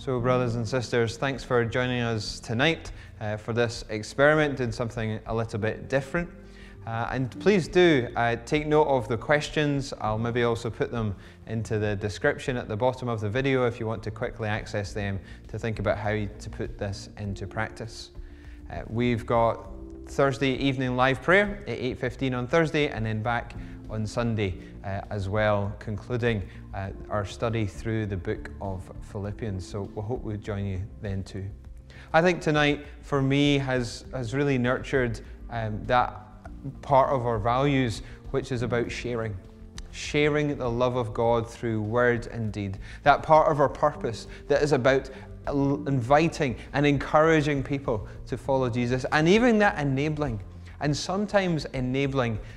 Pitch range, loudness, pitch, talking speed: 105-135 Hz, -26 LUFS, 120 Hz, 165 wpm